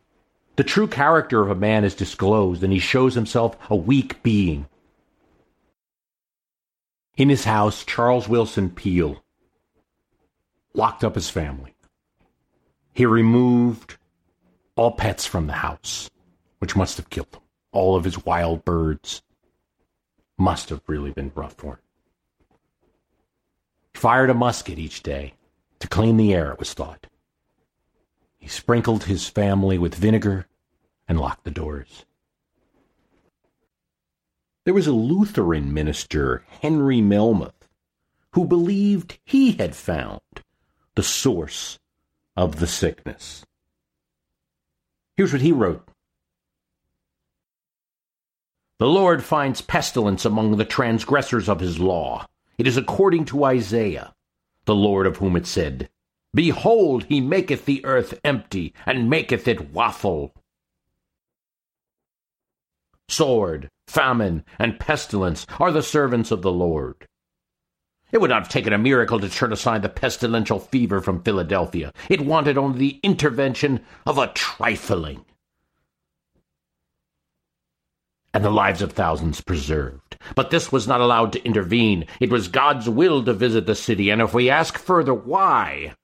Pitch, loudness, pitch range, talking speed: 105 Hz, -21 LUFS, 85-125 Hz, 130 wpm